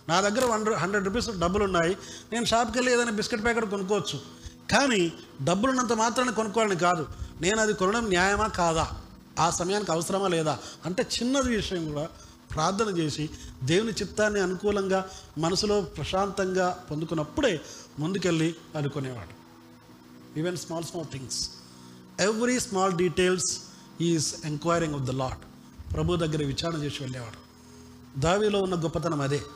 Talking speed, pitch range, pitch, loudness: 130 wpm, 145-205 Hz, 175 Hz, -27 LUFS